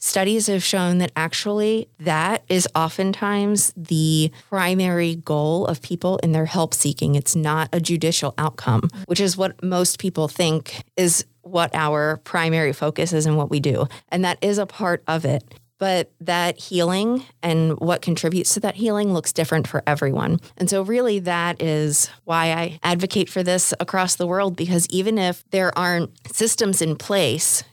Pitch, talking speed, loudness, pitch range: 170 Hz, 170 wpm, -21 LUFS, 155-185 Hz